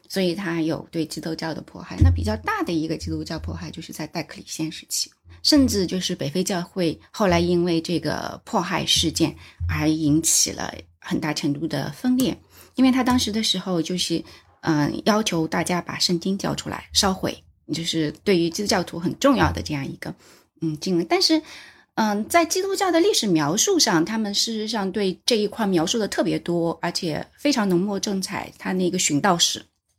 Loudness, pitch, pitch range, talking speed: -22 LUFS, 175 Hz, 160-210 Hz, 290 characters per minute